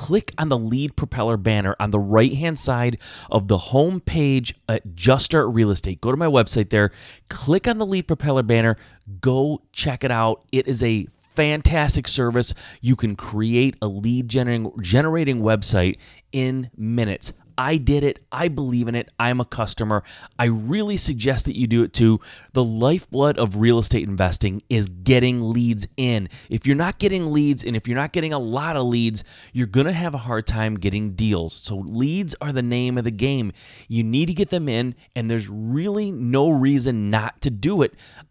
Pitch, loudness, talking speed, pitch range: 120 Hz, -21 LUFS, 190 wpm, 110-140 Hz